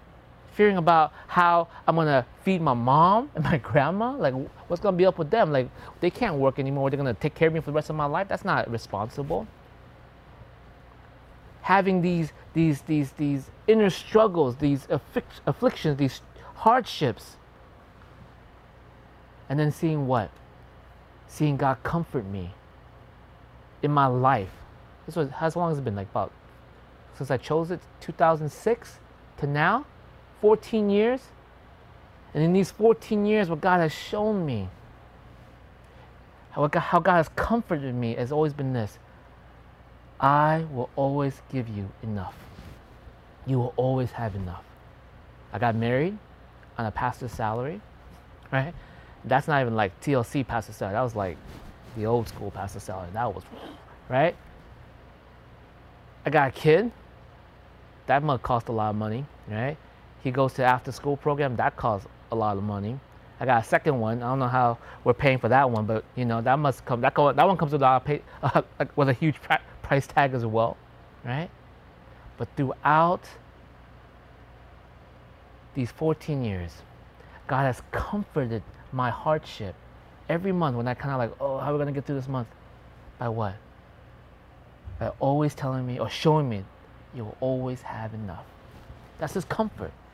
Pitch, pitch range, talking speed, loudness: 135 Hz, 110-155 Hz, 160 wpm, -26 LUFS